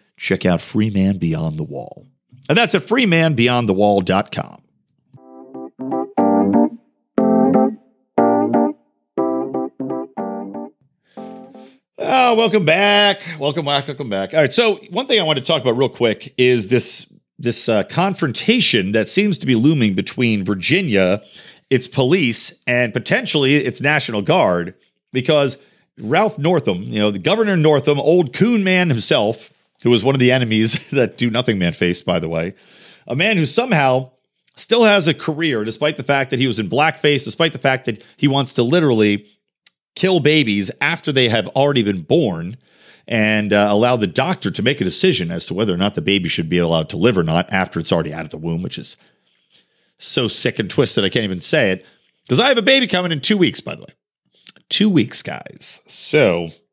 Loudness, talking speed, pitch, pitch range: -17 LUFS, 175 wpm, 130 Hz, 105-165 Hz